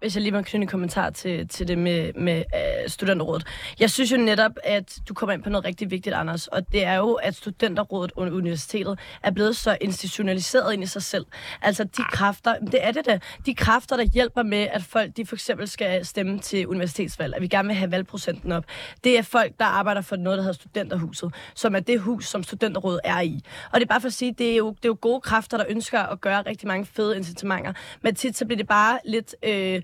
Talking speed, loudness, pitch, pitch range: 240 wpm, -24 LUFS, 205 Hz, 185-225 Hz